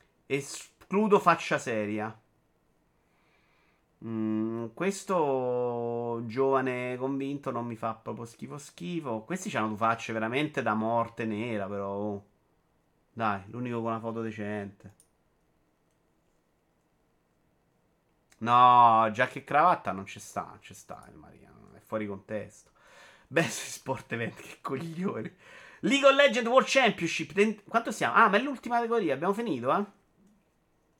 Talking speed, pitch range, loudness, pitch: 125 wpm, 110-170 Hz, -28 LUFS, 125 Hz